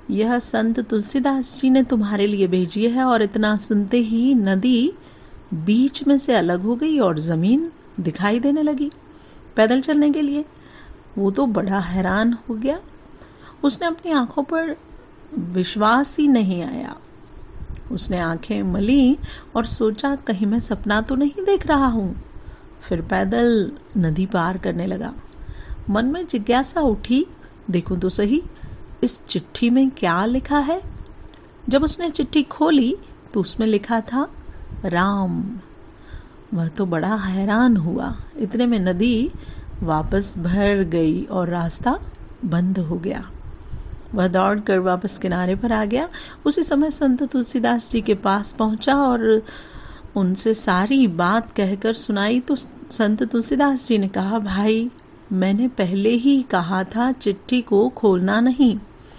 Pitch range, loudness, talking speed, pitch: 195-270 Hz, -20 LUFS, 140 wpm, 225 Hz